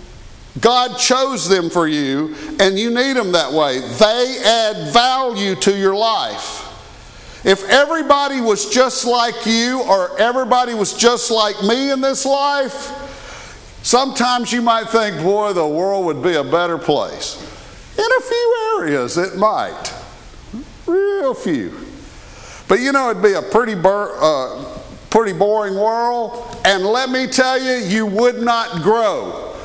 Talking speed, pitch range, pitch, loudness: 150 wpm, 195-255 Hz, 230 Hz, -16 LUFS